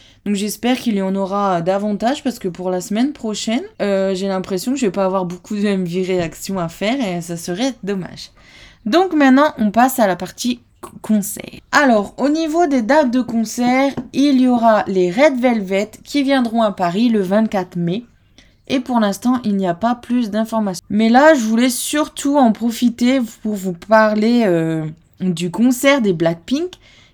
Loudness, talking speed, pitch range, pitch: -17 LUFS, 185 wpm, 195-255 Hz, 220 Hz